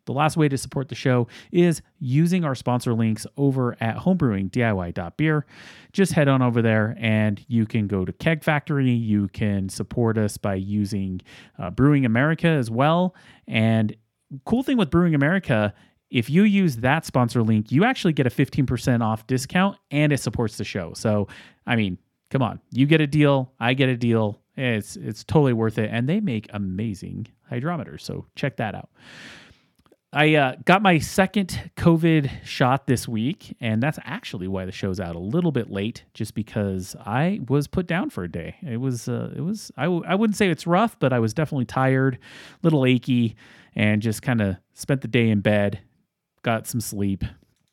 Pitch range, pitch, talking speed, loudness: 110-150 Hz, 125 Hz, 190 wpm, -23 LUFS